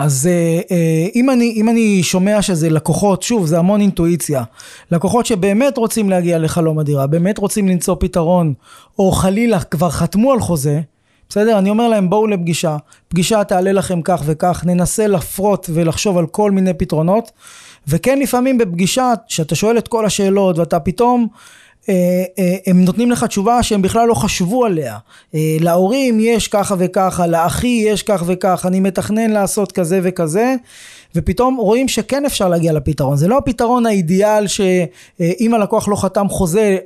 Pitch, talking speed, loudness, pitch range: 190 Hz, 160 wpm, -15 LUFS, 175-220 Hz